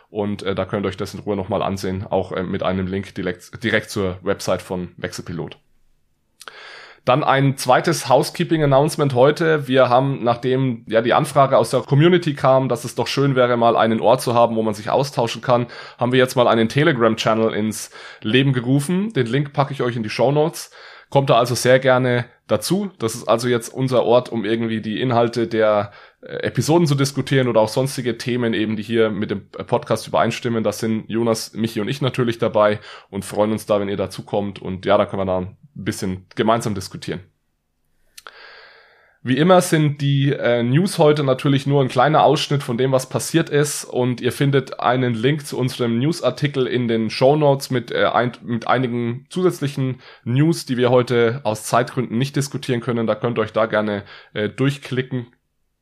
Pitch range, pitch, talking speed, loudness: 110-135 Hz, 120 Hz, 190 wpm, -19 LUFS